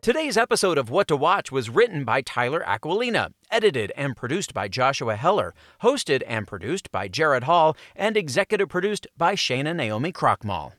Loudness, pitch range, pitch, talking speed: -23 LUFS, 170-235 Hz, 205 Hz, 165 wpm